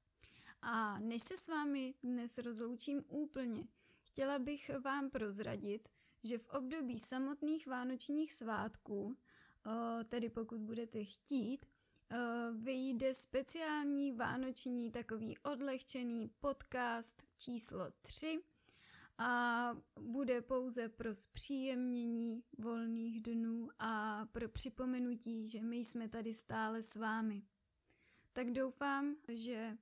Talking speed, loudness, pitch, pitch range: 100 wpm, -40 LUFS, 240 Hz, 230-265 Hz